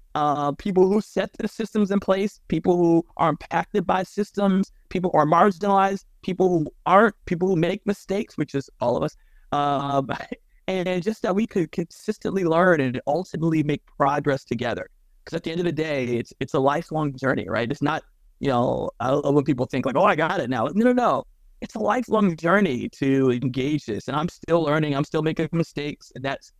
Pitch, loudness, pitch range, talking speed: 170 Hz, -23 LUFS, 145-195 Hz, 200 wpm